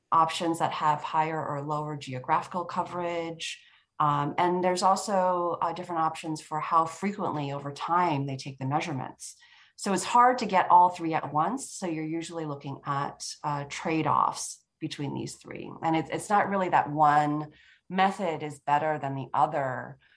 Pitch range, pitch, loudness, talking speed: 150-175 Hz, 160 Hz, -28 LUFS, 170 wpm